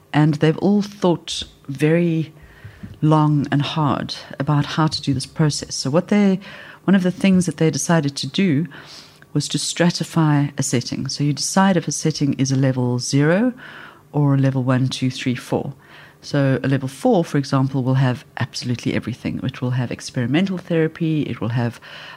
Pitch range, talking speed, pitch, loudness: 135-165 Hz, 180 wpm, 145 Hz, -20 LUFS